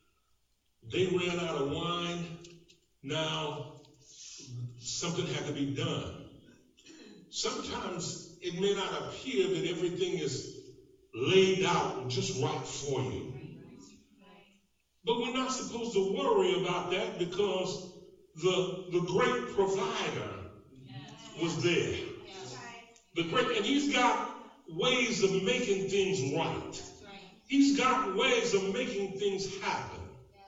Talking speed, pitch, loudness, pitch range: 110 wpm, 185 Hz, -31 LUFS, 160-205 Hz